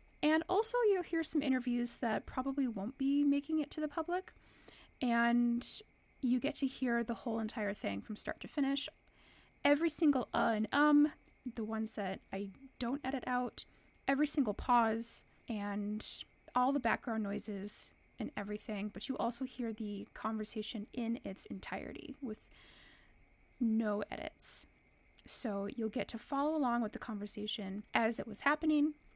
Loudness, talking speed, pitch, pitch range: -36 LUFS, 155 wpm, 240 Hz, 215-280 Hz